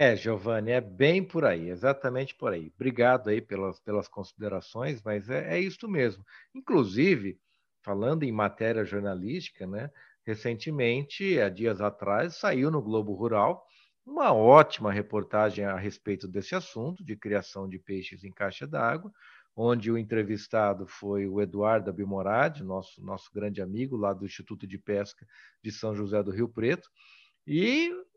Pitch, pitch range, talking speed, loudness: 110 Hz, 100-130 Hz, 150 wpm, -29 LUFS